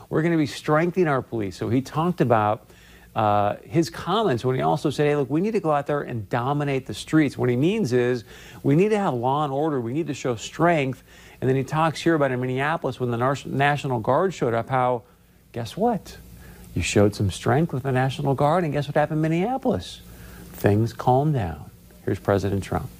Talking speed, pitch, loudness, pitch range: 220 wpm, 135 Hz, -23 LUFS, 115-155 Hz